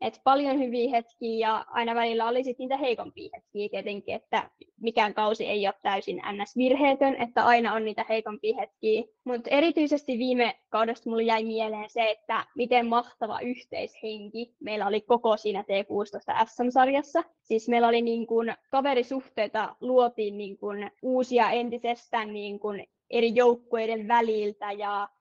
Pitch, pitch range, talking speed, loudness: 230 Hz, 215-245 Hz, 150 wpm, -27 LUFS